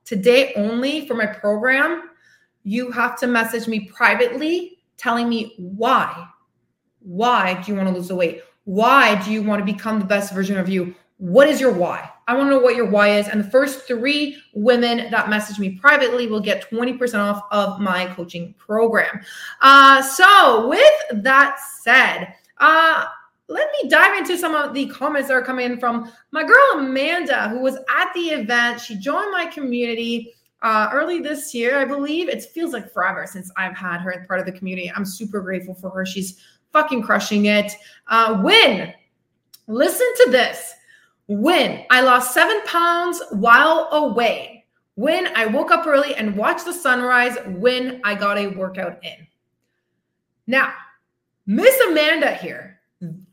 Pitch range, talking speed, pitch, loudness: 205-285 Hz, 170 wpm, 240 Hz, -17 LUFS